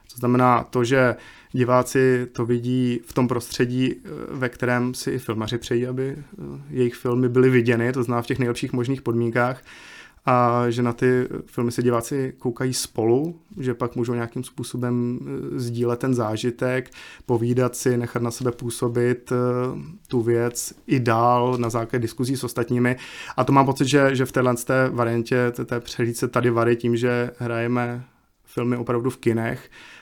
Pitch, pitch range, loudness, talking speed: 125 Hz, 120-130 Hz, -23 LUFS, 160 wpm